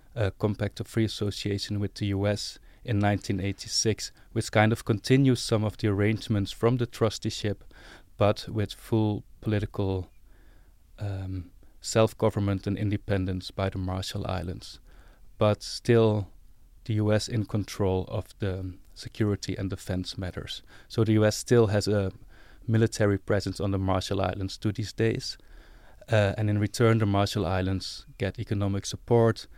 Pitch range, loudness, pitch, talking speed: 95-110 Hz, -28 LUFS, 105 Hz, 140 wpm